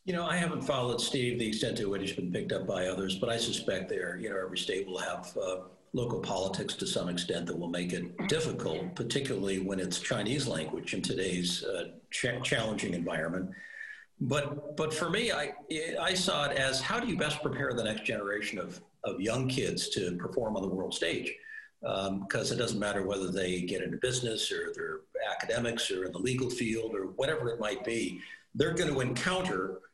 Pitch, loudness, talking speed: 130 Hz, -33 LUFS, 205 wpm